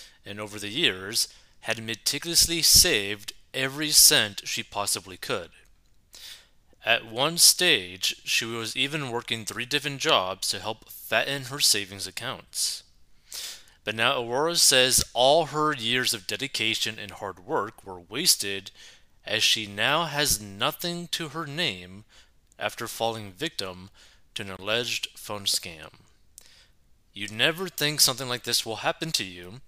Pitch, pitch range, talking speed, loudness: 115 Hz, 100-150 Hz, 135 wpm, -24 LUFS